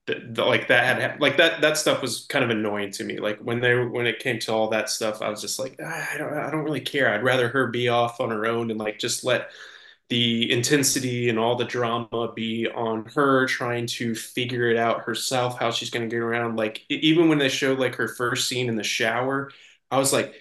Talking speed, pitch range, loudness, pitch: 245 wpm, 115-130 Hz, -23 LUFS, 120 Hz